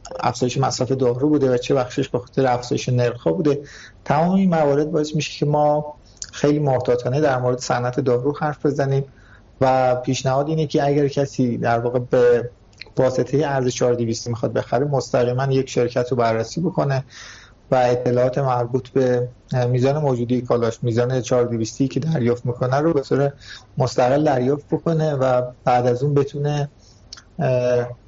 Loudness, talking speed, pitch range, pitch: -20 LUFS, 150 wpm, 120-140 Hz, 130 Hz